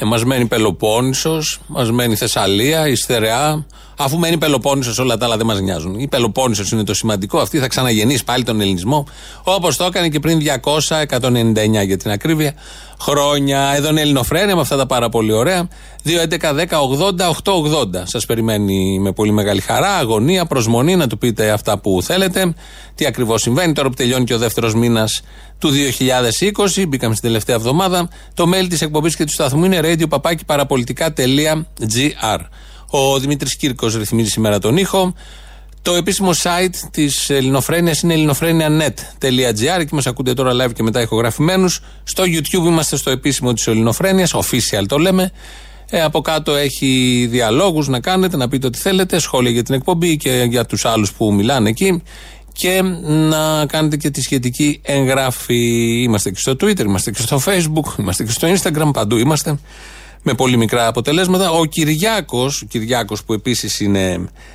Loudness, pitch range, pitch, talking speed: -15 LUFS, 115-160 Hz, 135 Hz, 160 wpm